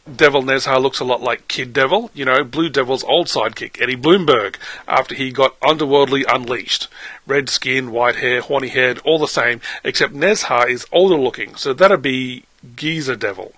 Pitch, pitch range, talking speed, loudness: 140 Hz, 130-185 Hz, 175 wpm, -16 LUFS